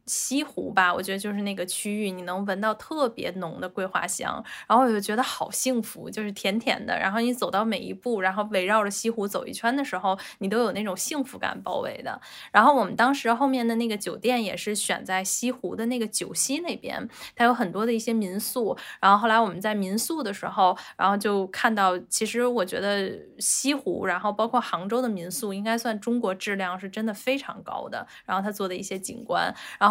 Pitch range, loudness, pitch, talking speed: 190-235 Hz, -26 LUFS, 215 Hz, 325 characters per minute